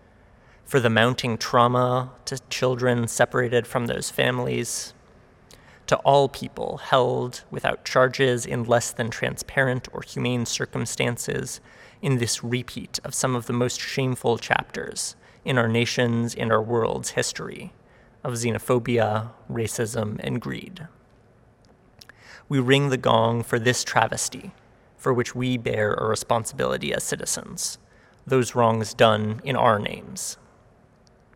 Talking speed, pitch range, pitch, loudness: 125 wpm, 115-125 Hz, 120 Hz, -24 LUFS